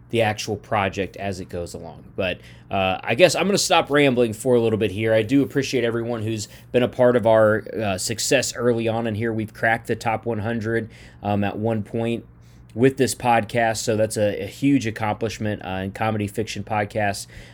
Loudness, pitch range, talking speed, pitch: -22 LUFS, 105-120 Hz, 205 wpm, 110 Hz